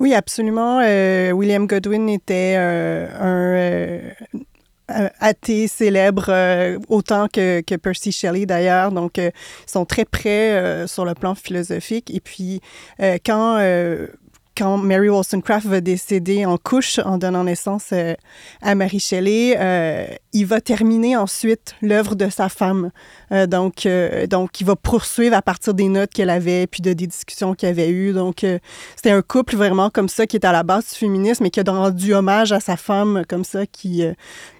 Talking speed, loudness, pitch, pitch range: 180 wpm, -18 LUFS, 195 Hz, 180-210 Hz